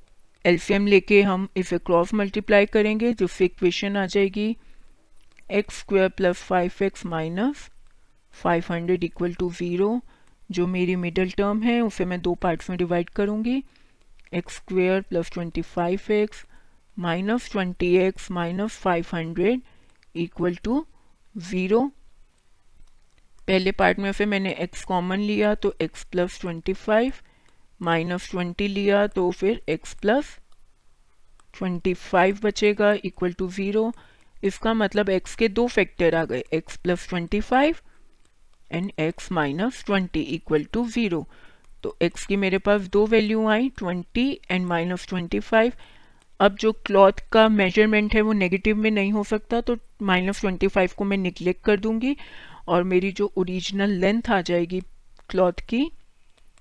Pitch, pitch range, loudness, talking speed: 195 Hz, 180-215 Hz, -23 LUFS, 145 wpm